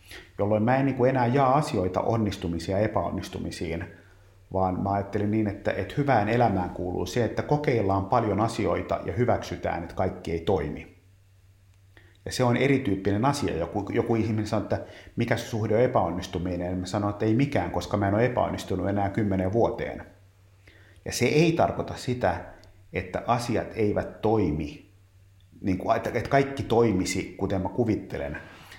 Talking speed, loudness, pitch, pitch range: 165 wpm, -26 LUFS, 100 Hz, 95-115 Hz